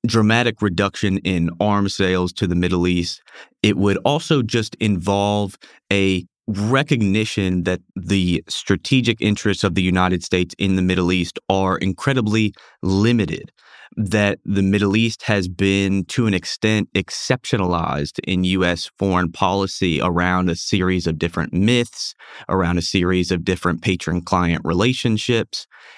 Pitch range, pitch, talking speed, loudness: 90-105 Hz, 95 Hz, 135 wpm, -19 LUFS